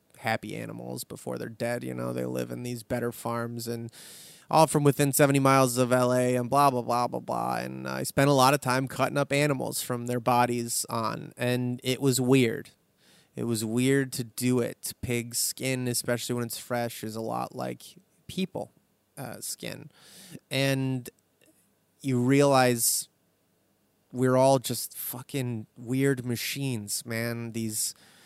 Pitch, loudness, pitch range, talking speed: 125 Hz, -27 LUFS, 115-135 Hz, 160 wpm